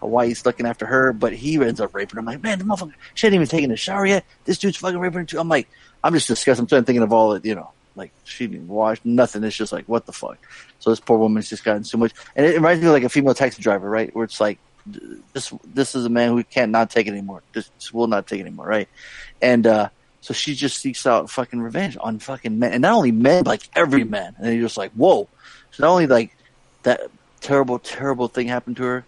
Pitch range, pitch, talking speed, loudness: 115-145 Hz, 120 Hz, 265 wpm, -20 LUFS